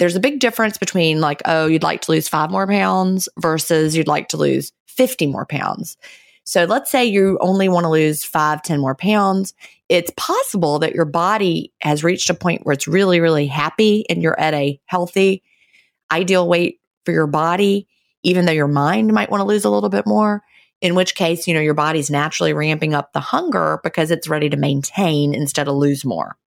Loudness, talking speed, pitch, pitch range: -17 LUFS, 205 wpm, 165 Hz, 150-190 Hz